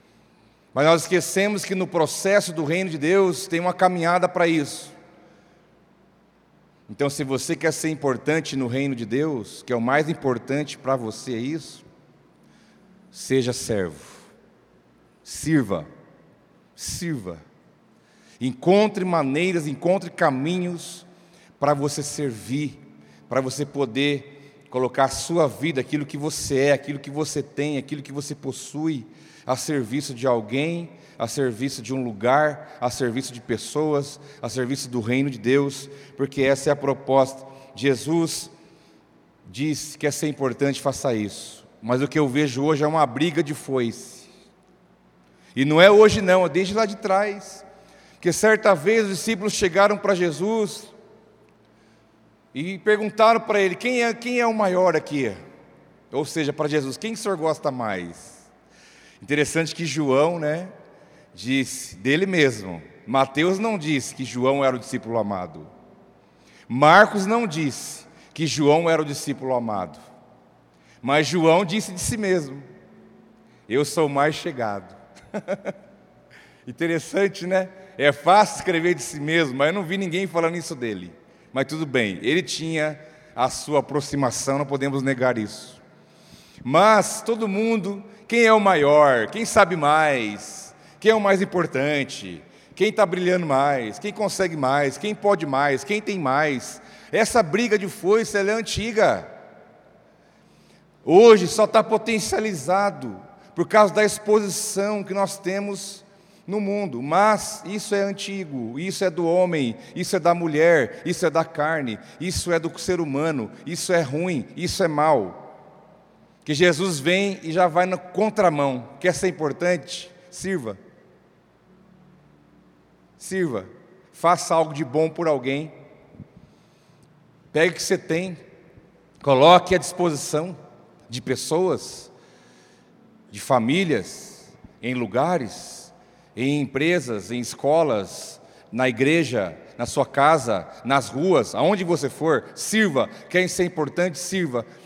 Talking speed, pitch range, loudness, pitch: 140 wpm, 135-185 Hz, -22 LUFS, 160 Hz